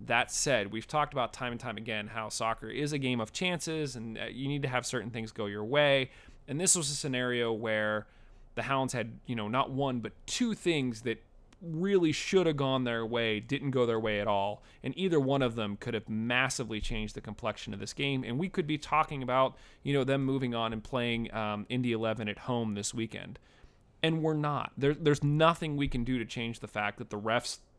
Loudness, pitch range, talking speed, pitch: -32 LUFS, 110-140 Hz, 225 wpm, 125 Hz